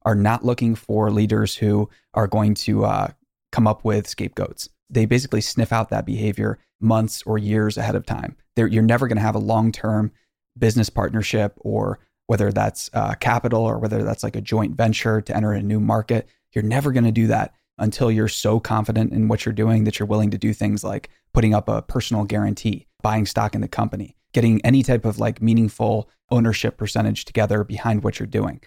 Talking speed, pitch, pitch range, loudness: 205 wpm, 110 Hz, 105-115 Hz, -21 LUFS